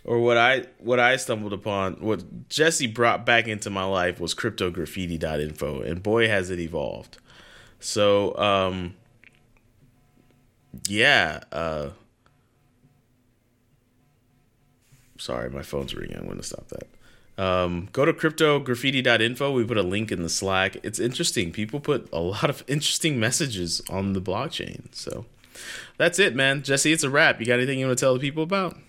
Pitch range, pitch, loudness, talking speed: 95-130 Hz, 120 Hz, -23 LUFS, 155 wpm